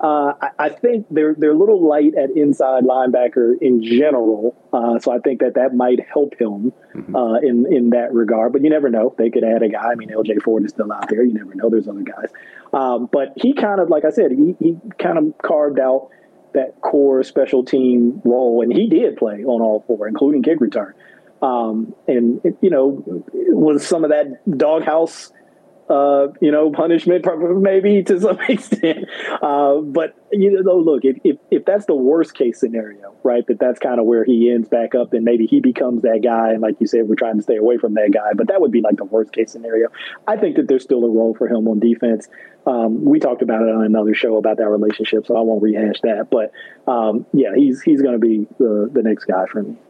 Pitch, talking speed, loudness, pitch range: 125 Hz, 230 wpm, -16 LUFS, 115-155 Hz